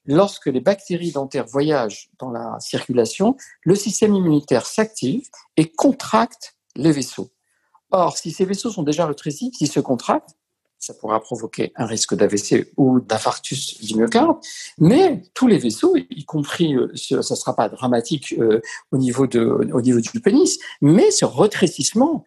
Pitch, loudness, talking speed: 150 Hz, -19 LUFS, 155 wpm